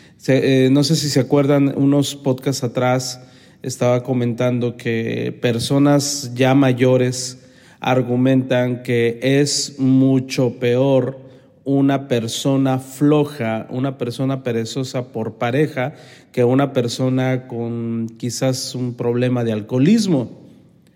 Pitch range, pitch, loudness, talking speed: 125-135 Hz, 130 Hz, -18 LUFS, 105 wpm